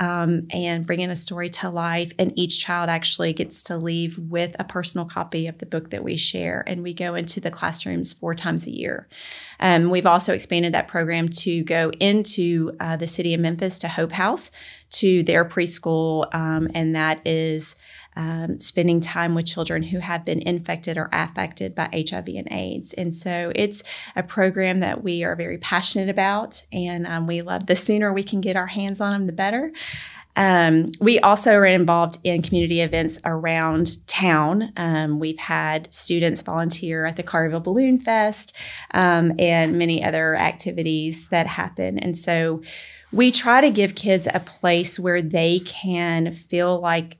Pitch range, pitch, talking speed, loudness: 165-185 Hz, 170 Hz, 180 wpm, -20 LUFS